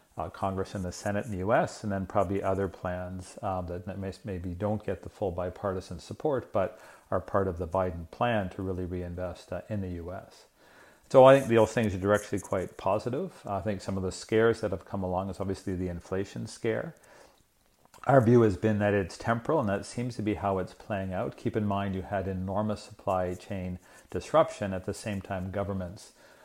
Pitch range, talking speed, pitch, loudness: 90-105 Hz, 210 wpm, 95 Hz, -30 LUFS